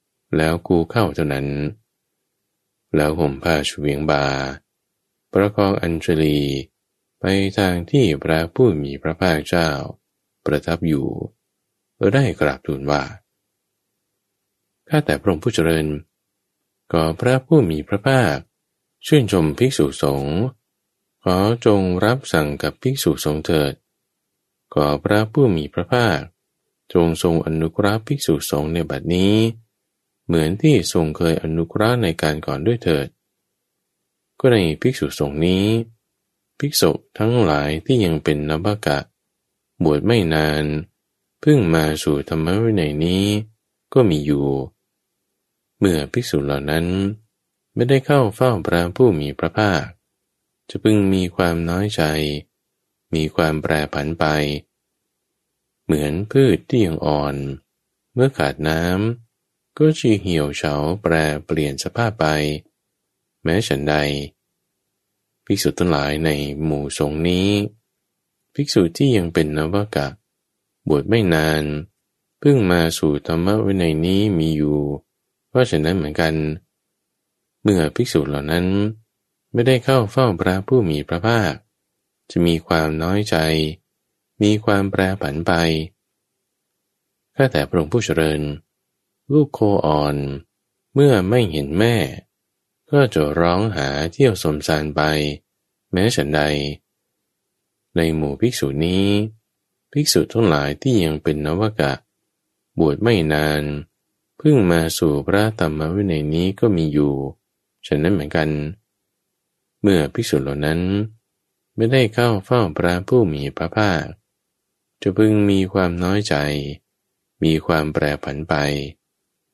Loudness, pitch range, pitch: -19 LUFS, 75-105 Hz, 85 Hz